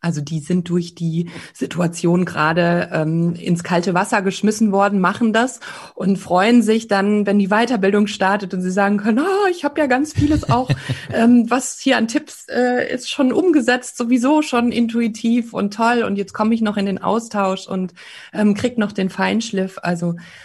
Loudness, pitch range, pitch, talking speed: -18 LUFS, 185-240 Hz, 205 Hz, 185 wpm